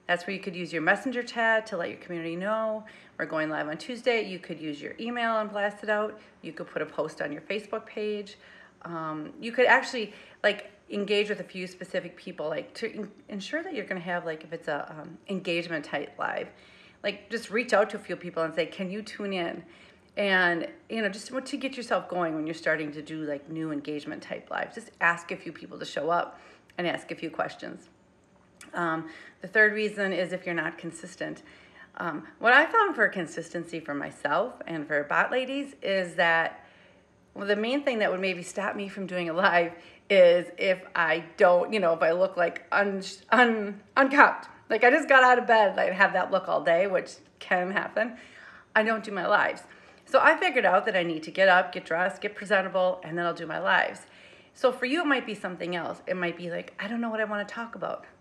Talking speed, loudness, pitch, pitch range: 225 wpm, -27 LUFS, 195 Hz, 170-220 Hz